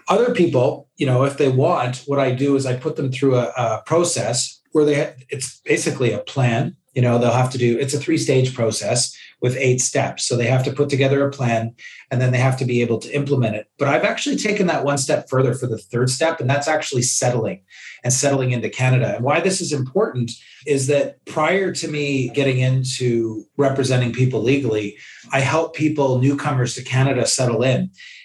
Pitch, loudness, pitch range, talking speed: 130 Hz, -19 LUFS, 125-145 Hz, 210 wpm